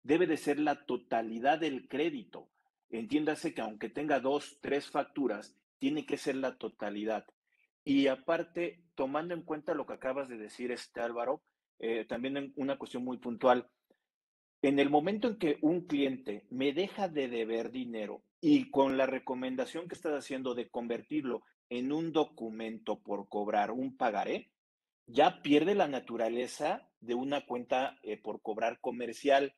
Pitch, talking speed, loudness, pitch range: 135 Hz, 160 wpm, -34 LUFS, 120-150 Hz